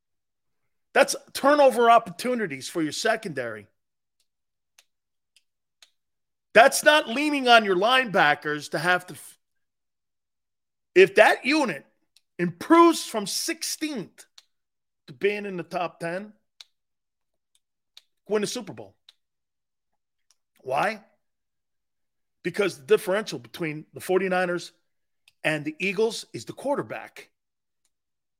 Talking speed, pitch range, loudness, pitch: 95 wpm, 165-235 Hz, -23 LUFS, 190 Hz